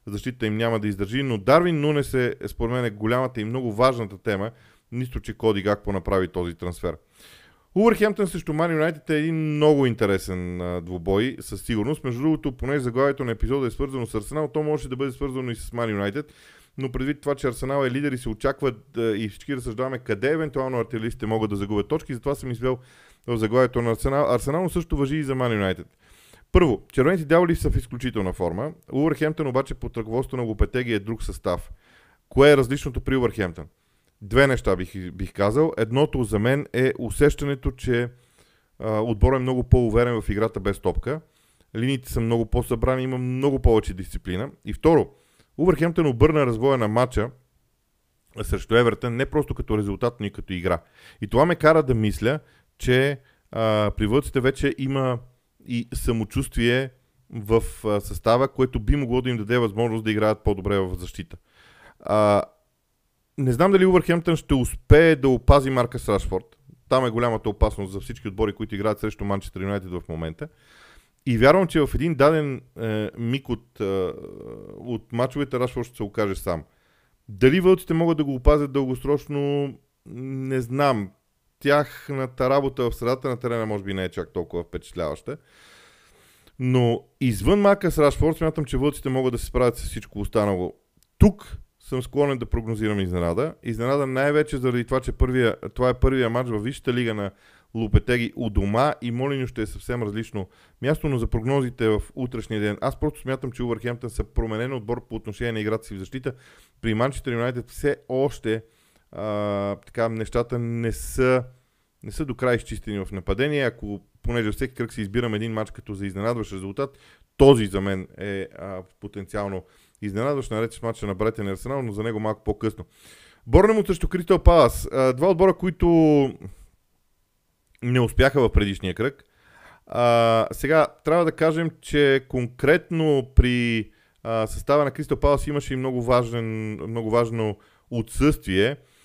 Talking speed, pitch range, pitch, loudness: 170 wpm, 105-140 Hz, 120 Hz, -23 LUFS